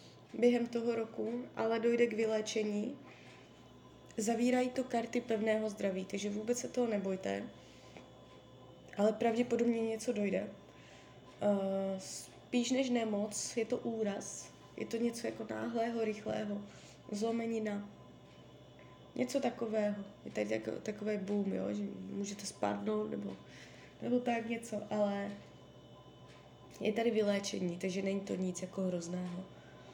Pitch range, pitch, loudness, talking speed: 200-235 Hz, 215 Hz, -36 LUFS, 115 wpm